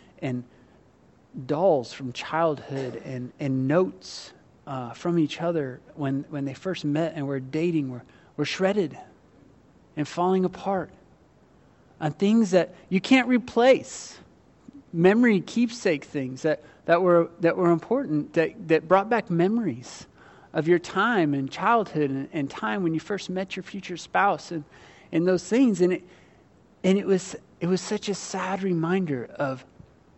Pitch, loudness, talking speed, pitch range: 170 Hz, -25 LUFS, 150 wpm, 145-190 Hz